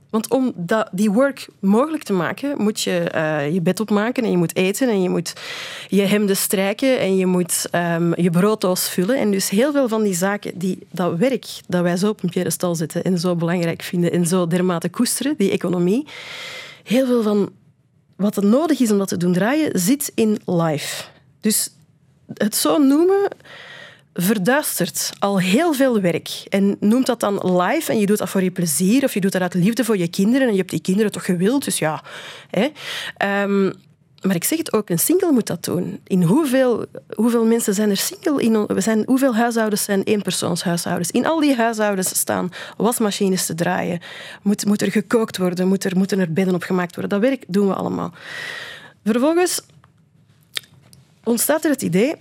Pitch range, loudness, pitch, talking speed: 180-235 Hz, -19 LUFS, 200 Hz, 190 wpm